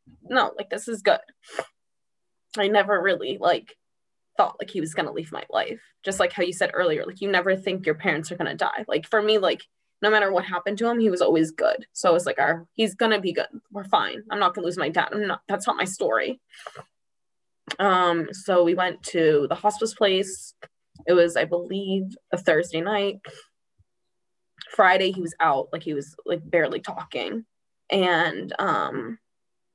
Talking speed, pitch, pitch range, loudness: 195 wpm, 190 Hz, 175-210 Hz, -24 LUFS